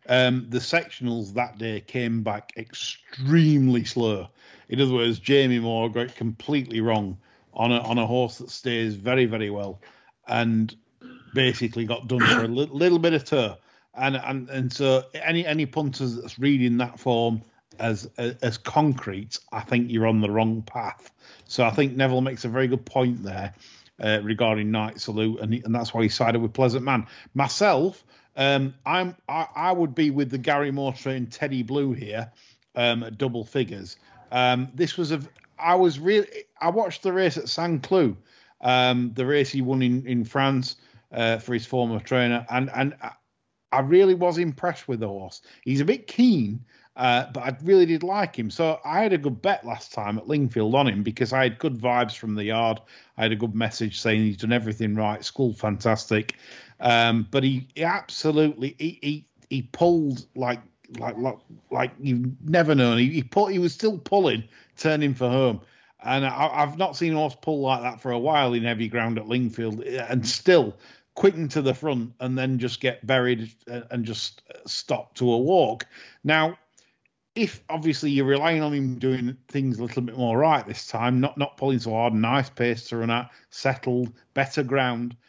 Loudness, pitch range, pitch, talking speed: -24 LUFS, 115-140 Hz, 125 Hz, 190 wpm